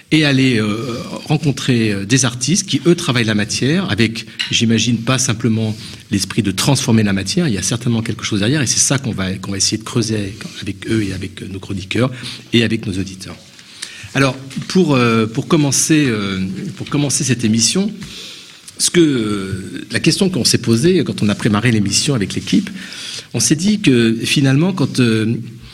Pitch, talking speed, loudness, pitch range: 120 Hz, 185 wpm, -16 LUFS, 110-140 Hz